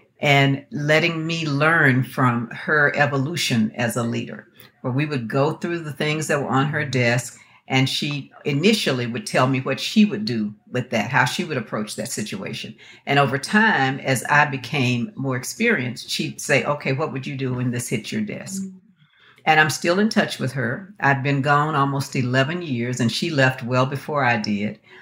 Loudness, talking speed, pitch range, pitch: -21 LUFS, 190 wpm, 125-155 Hz, 140 Hz